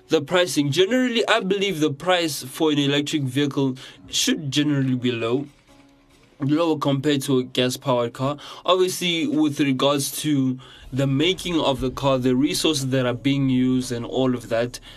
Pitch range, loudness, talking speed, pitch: 130-155 Hz, -22 LUFS, 165 wpm, 140 Hz